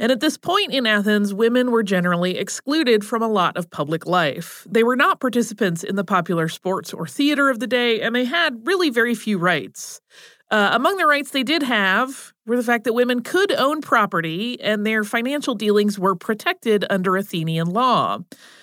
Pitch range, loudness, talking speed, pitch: 190-260 Hz, -20 LUFS, 195 wpm, 230 Hz